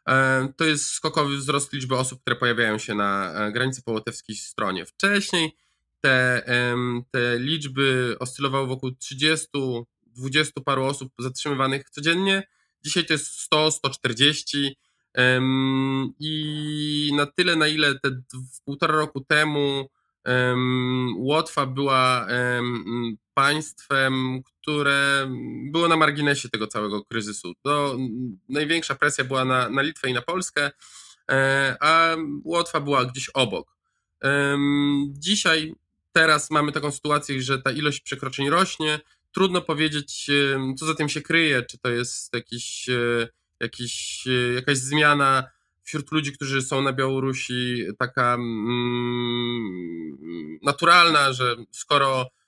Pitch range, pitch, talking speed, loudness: 125-150 Hz, 135 Hz, 110 wpm, -23 LUFS